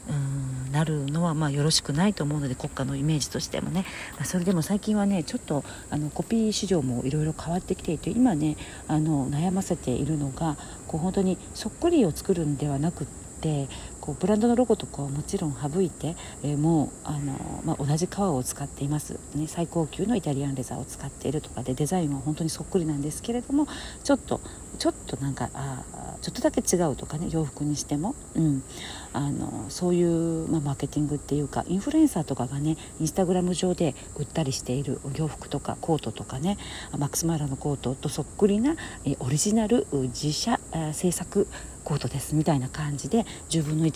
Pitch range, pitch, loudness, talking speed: 140-180 Hz, 155 Hz, -27 LUFS, 410 characters per minute